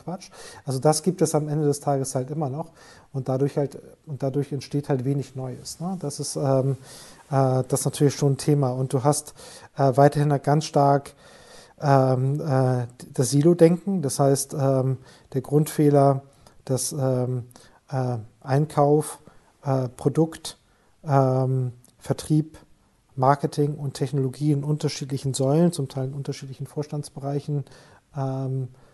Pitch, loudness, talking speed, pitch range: 140 Hz, -24 LUFS, 145 wpm, 135-150 Hz